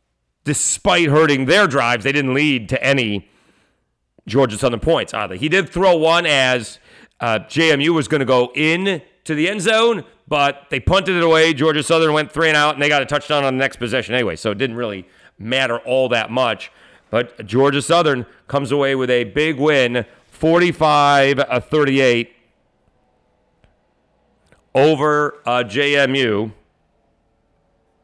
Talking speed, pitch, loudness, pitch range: 150 wpm, 140 Hz, -16 LUFS, 120-155 Hz